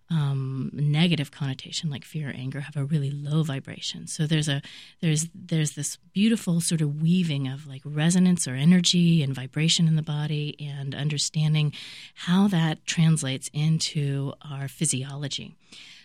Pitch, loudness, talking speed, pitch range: 150 Hz, -25 LUFS, 150 wpm, 140-165 Hz